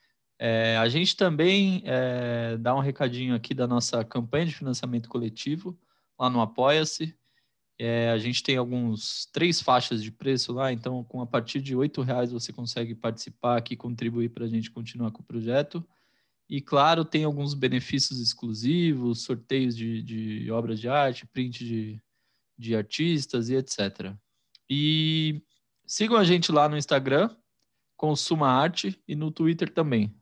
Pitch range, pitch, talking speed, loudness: 115-150 Hz, 125 Hz, 155 wpm, -27 LUFS